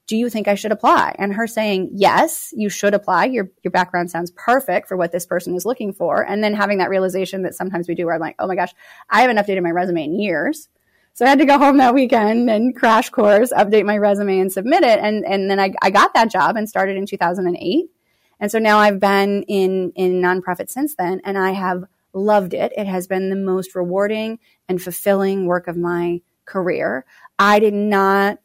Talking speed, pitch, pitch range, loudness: 225 wpm, 195 Hz, 185-215 Hz, -17 LUFS